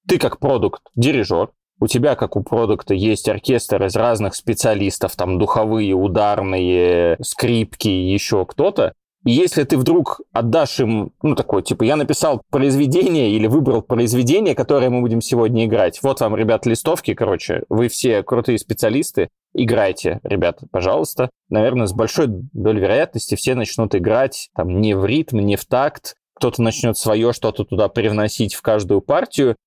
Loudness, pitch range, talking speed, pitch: -18 LUFS, 100-120 Hz, 155 wpm, 110 Hz